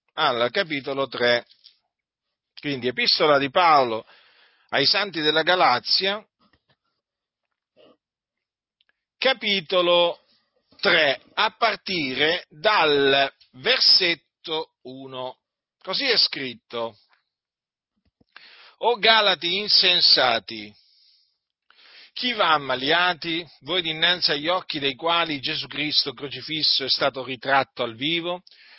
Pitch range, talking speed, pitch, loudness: 135-180 Hz, 85 wpm, 155 Hz, -20 LUFS